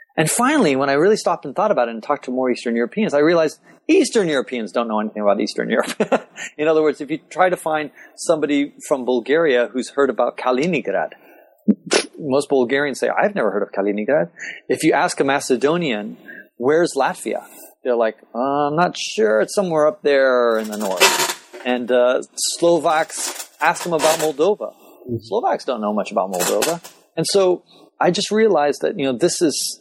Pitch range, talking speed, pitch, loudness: 125-170 Hz, 185 wpm, 145 Hz, -19 LUFS